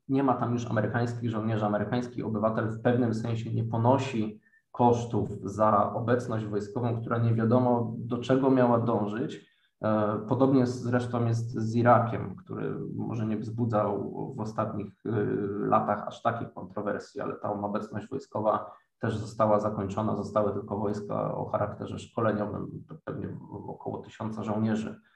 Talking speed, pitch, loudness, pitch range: 135 wpm, 110 Hz, -29 LUFS, 105-120 Hz